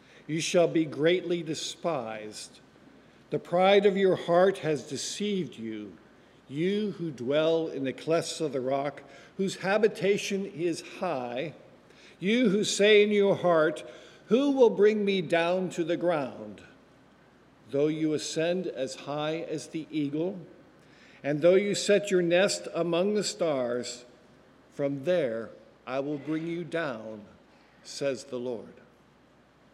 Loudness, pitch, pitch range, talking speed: -28 LUFS, 165 Hz, 140-185 Hz, 135 wpm